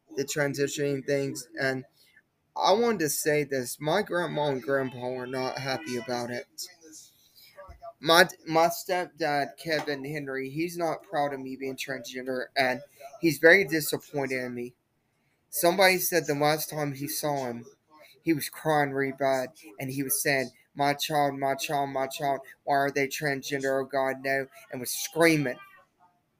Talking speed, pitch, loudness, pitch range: 155 wpm, 140 Hz, -27 LUFS, 135-155 Hz